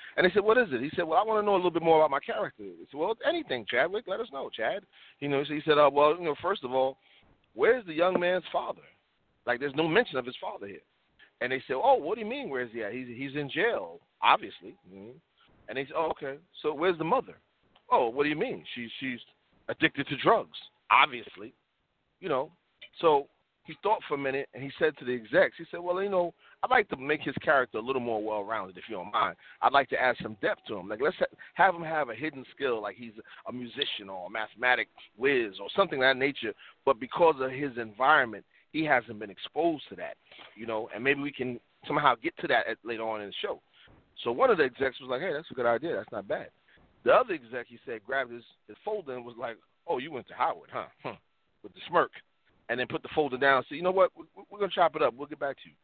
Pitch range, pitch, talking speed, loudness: 125-165 Hz, 140 Hz, 260 wpm, -29 LUFS